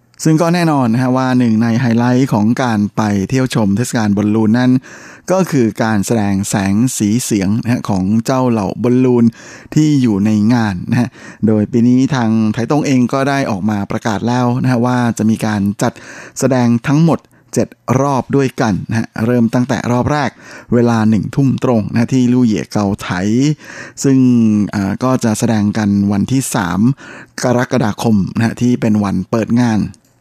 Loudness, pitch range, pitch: -14 LUFS, 110-130 Hz, 120 Hz